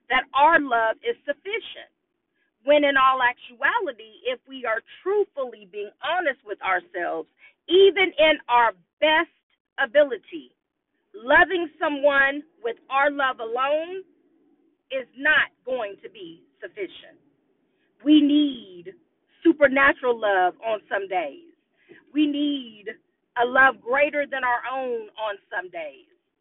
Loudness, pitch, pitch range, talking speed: -22 LUFS, 305 Hz, 265-345 Hz, 120 wpm